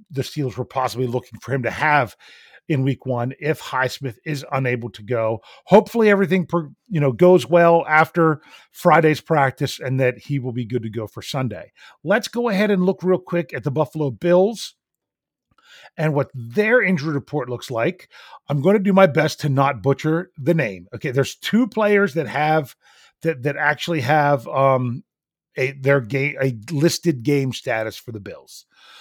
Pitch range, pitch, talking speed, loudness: 130-170 Hz, 145 Hz, 180 wpm, -20 LUFS